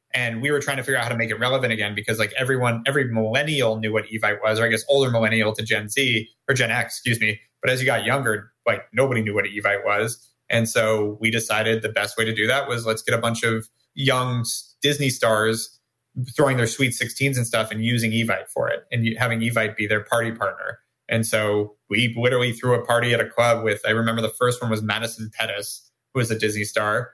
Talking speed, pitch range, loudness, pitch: 235 wpm, 110-125 Hz, -22 LUFS, 115 Hz